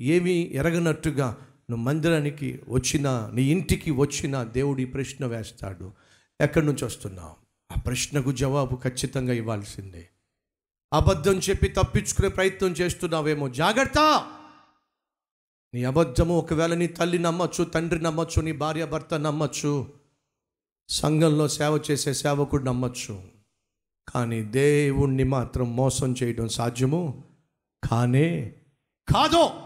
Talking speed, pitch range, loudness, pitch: 100 wpm, 125-160 Hz, -25 LUFS, 140 Hz